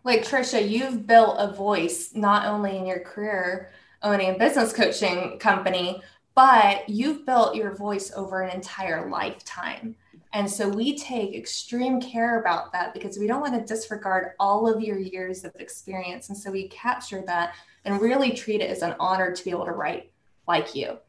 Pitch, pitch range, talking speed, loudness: 205 Hz, 185-225 Hz, 180 wpm, -24 LUFS